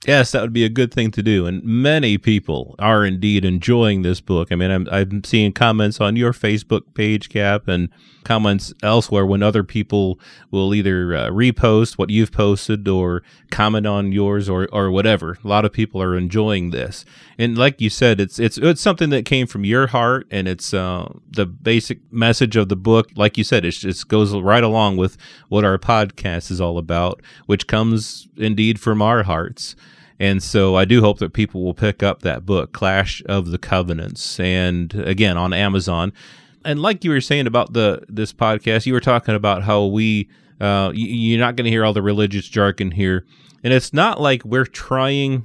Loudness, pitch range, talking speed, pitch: -18 LUFS, 95-115 Hz, 195 wpm, 105 Hz